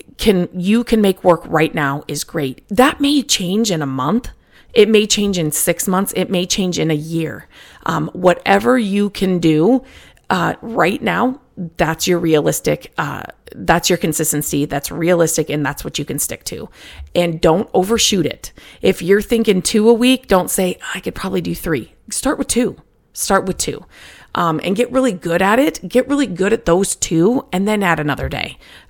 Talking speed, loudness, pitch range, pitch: 190 wpm, -16 LUFS, 165-220 Hz, 185 Hz